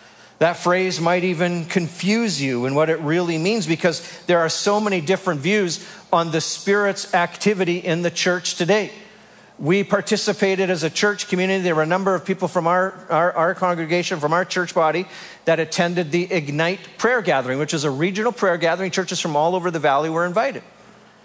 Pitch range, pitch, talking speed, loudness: 165-190 Hz, 180 Hz, 190 wpm, -20 LUFS